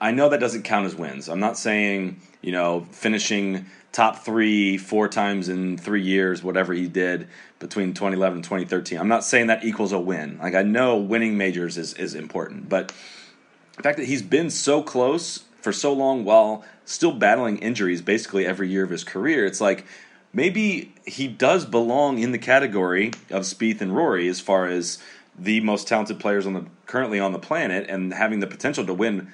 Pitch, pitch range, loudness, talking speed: 100 Hz, 95-110 Hz, -23 LUFS, 195 wpm